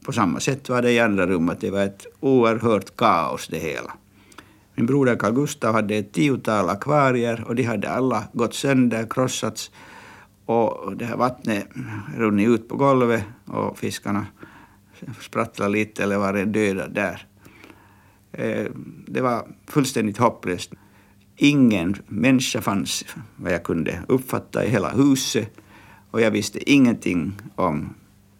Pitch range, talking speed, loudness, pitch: 100-130 Hz, 135 wpm, -22 LUFS, 115 Hz